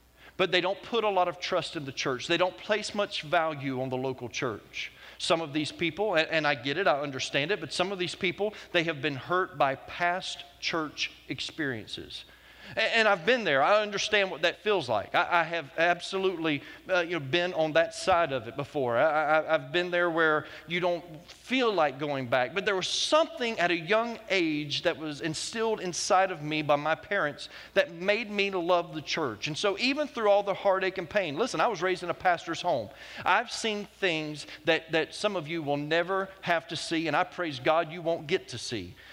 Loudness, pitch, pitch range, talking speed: -28 LUFS, 175 Hz, 155-190 Hz, 220 wpm